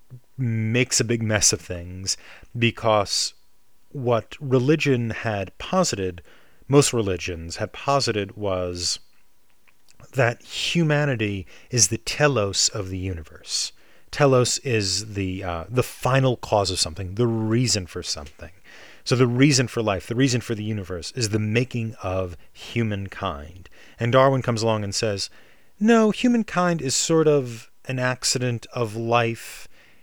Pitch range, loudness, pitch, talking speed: 95-130 Hz, -23 LUFS, 115 Hz, 135 wpm